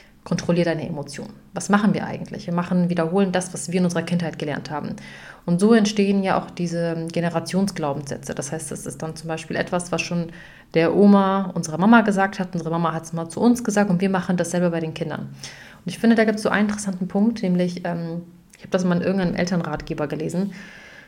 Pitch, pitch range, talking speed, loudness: 175 Hz, 165-195 Hz, 215 wpm, -22 LUFS